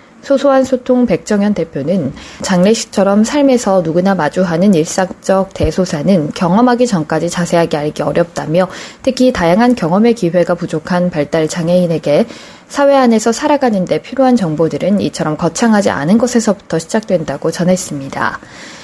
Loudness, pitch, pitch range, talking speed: -13 LUFS, 185 Hz, 165-235 Hz, 355 characters per minute